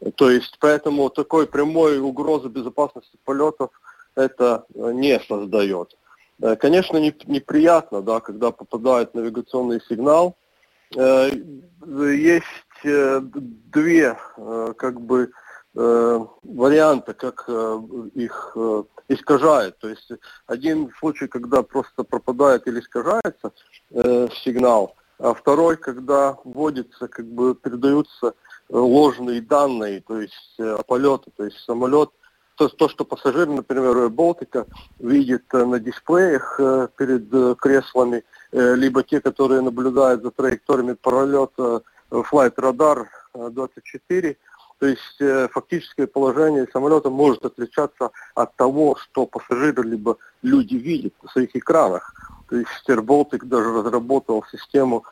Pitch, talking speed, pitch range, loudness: 130 Hz, 105 wpm, 120-145 Hz, -20 LUFS